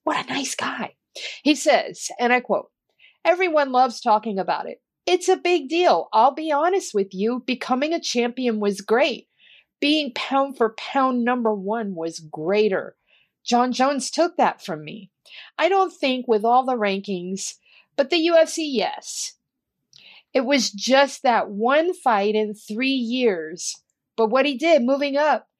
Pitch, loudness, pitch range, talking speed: 255 Hz, -21 LUFS, 215-300 Hz, 160 wpm